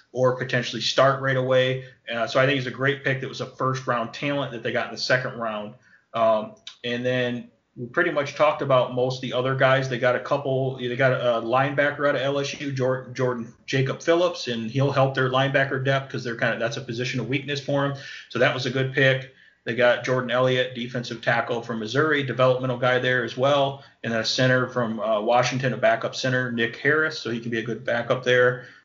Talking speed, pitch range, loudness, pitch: 225 wpm, 120-135 Hz, -23 LUFS, 130 Hz